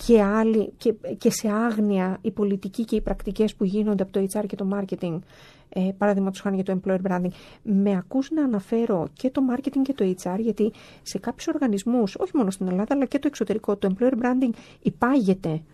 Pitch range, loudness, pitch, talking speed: 190-235 Hz, -24 LUFS, 210 Hz, 200 wpm